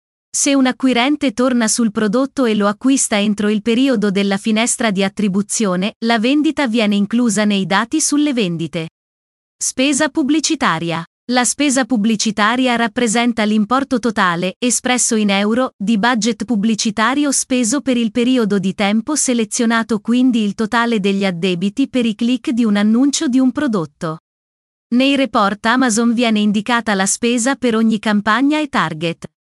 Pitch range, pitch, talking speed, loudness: 210-255 Hz, 230 Hz, 145 wpm, -16 LUFS